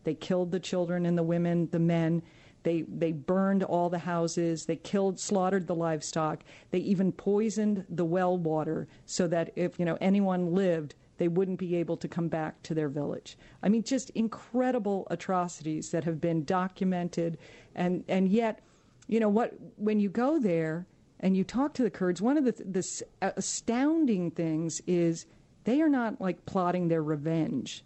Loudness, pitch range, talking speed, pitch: -30 LUFS, 165-195 Hz, 175 wpm, 180 Hz